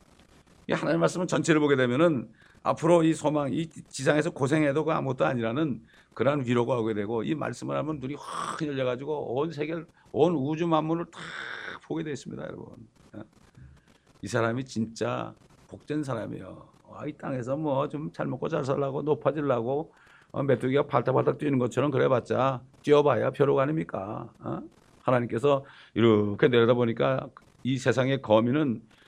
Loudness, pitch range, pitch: -27 LUFS, 120-150 Hz, 140 Hz